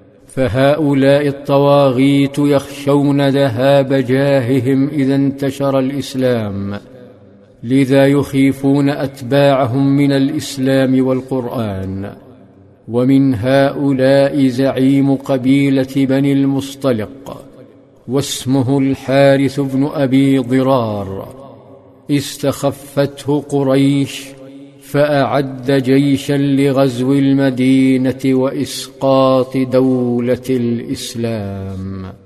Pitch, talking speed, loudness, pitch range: 135 Hz, 65 wpm, -14 LUFS, 130-140 Hz